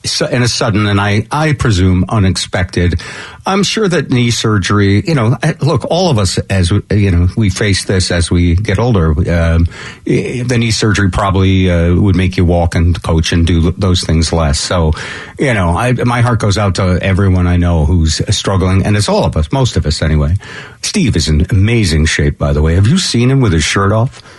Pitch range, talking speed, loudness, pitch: 85-115 Hz, 210 wpm, -12 LUFS, 95 Hz